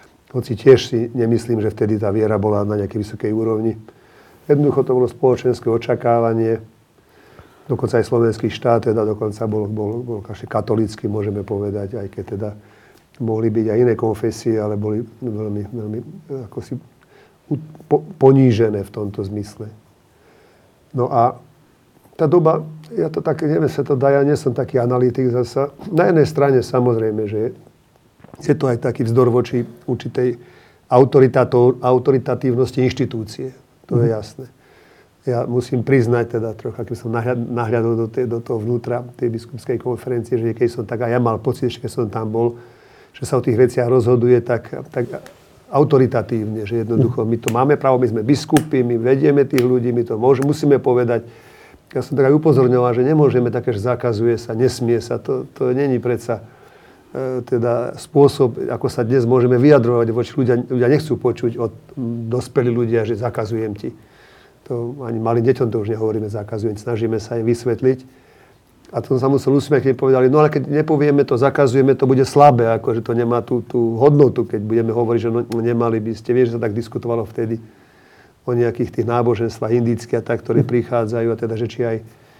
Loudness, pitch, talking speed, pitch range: -18 LUFS, 120 Hz, 175 wpm, 115-130 Hz